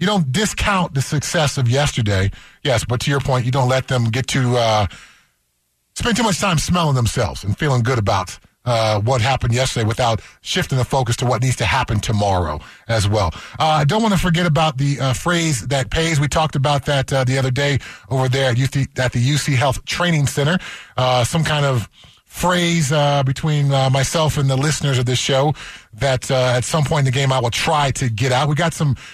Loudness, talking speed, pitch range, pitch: -18 LUFS, 220 wpm, 120-150 Hz, 135 Hz